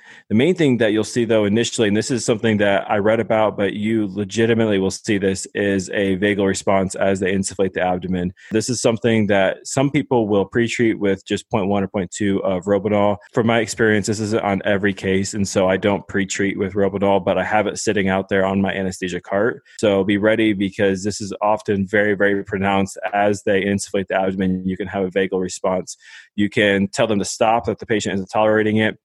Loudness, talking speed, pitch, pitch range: -19 LUFS, 220 wpm, 100 Hz, 95-110 Hz